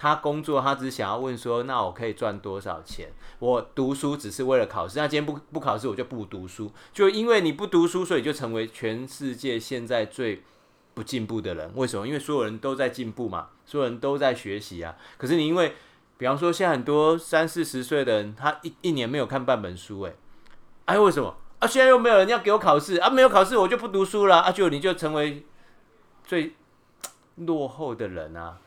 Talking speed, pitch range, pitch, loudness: 320 characters per minute, 120-165 Hz, 145 Hz, -24 LUFS